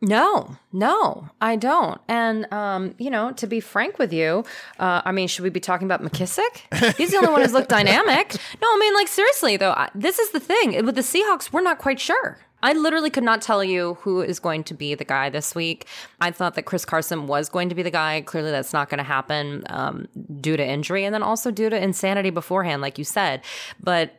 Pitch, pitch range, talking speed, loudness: 190 Hz, 165-245 Hz, 235 wpm, -21 LUFS